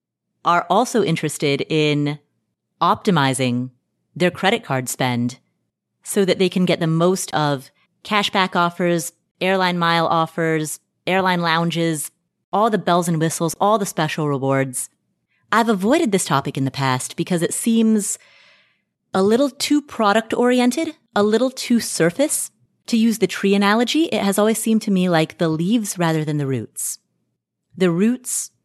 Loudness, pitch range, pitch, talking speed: -19 LUFS, 155-210 Hz, 175 Hz, 150 wpm